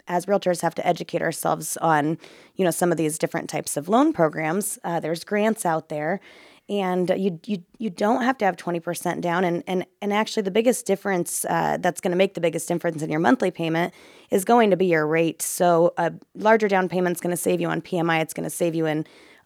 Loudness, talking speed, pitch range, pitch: -23 LUFS, 235 wpm, 165-195 Hz, 175 Hz